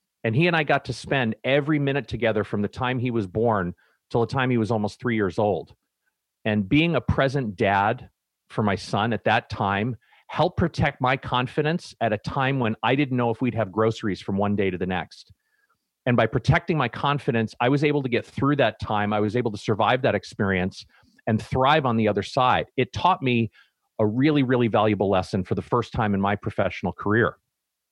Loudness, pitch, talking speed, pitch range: -24 LUFS, 115 Hz, 215 wpm, 105-135 Hz